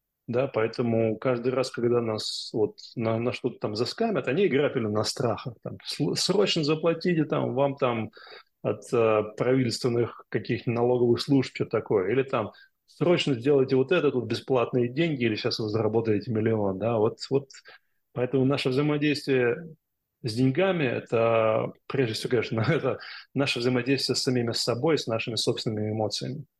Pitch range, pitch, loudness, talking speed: 115-140 Hz, 125 Hz, -26 LUFS, 150 wpm